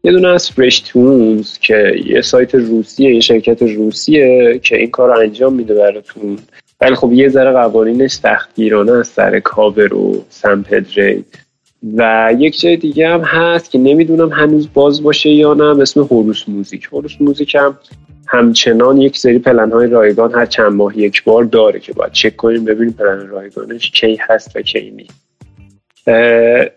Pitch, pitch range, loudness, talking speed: 120 Hz, 110-145 Hz, -10 LUFS, 160 wpm